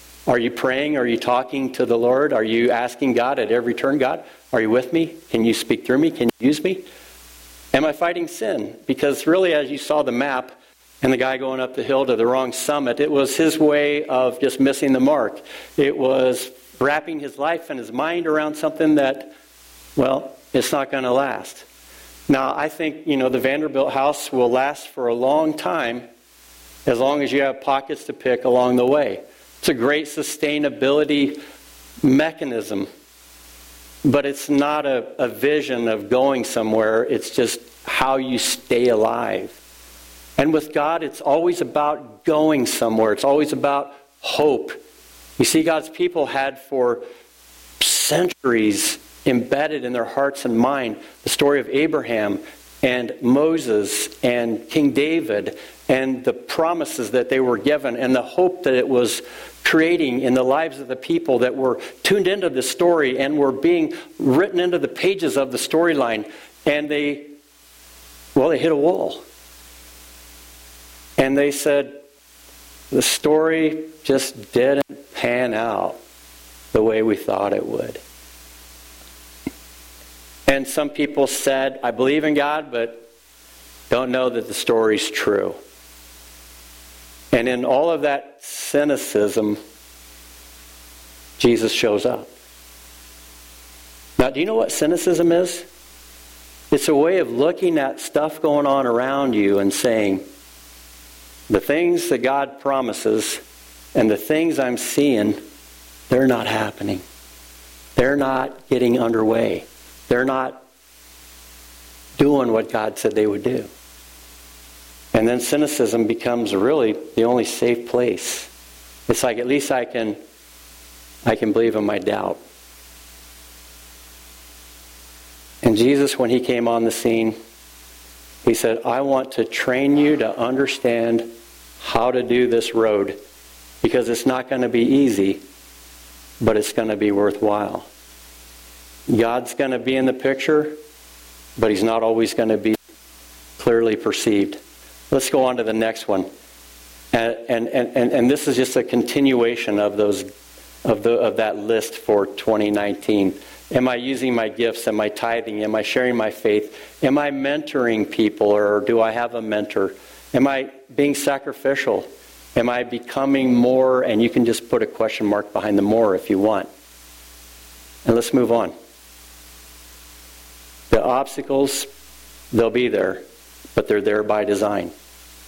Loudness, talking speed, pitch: -20 LUFS, 150 wpm, 120 Hz